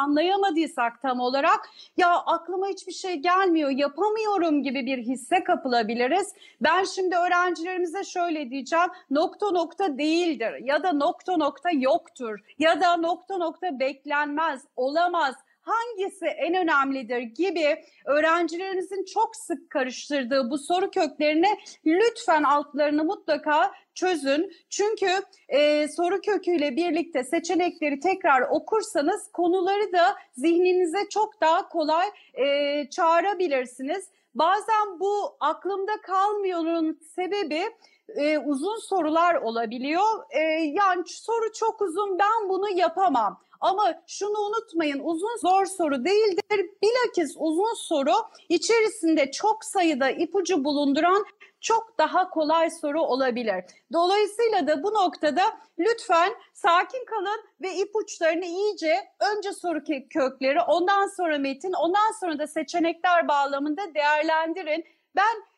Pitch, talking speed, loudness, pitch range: 345 Hz, 115 wpm, -25 LUFS, 305-390 Hz